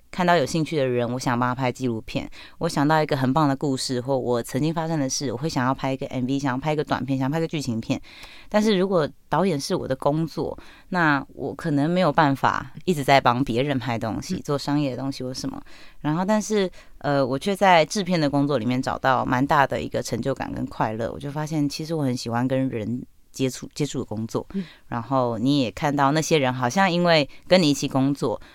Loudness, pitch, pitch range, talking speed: -23 LUFS, 140 Hz, 130-160 Hz, 335 characters per minute